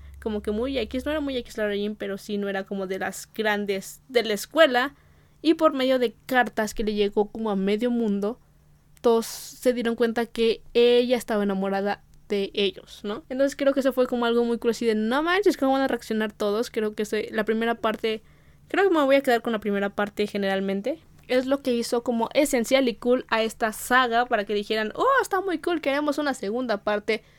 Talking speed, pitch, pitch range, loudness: 220 wpm, 230 Hz, 210-255 Hz, -25 LUFS